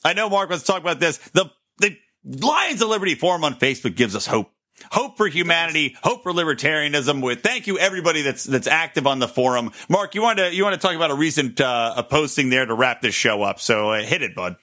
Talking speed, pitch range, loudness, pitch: 240 wpm, 130-190 Hz, -20 LUFS, 160 Hz